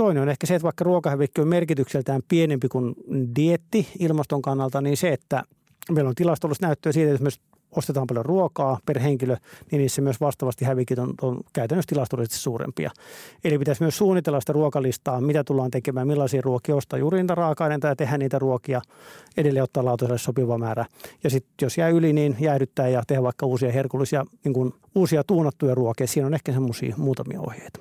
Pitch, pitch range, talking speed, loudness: 140 Hz, 130-155 Hz, 190 wpm, -24 LUFS